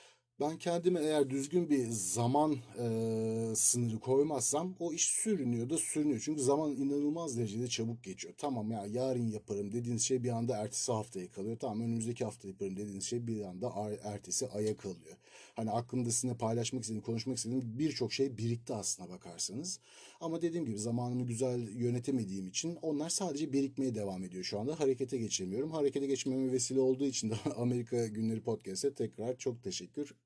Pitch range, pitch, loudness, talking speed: 110-140 Hz, 120 Hz, -35 LUFS, 165 wpm